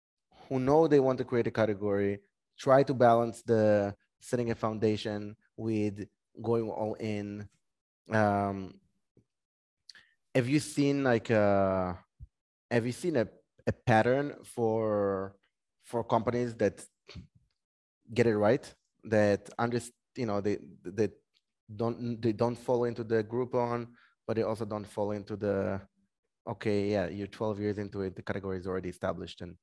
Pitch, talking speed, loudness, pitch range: 110 Hz, 145 wpm, -31 LUFS, 100-120 Hz